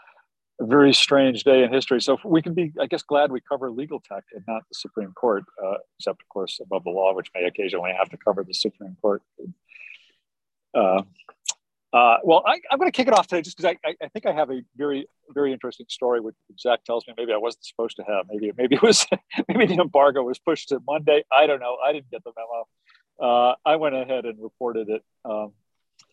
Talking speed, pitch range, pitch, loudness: 225 wpm, 115-150 Hz, 130 Hz, -22 LUFS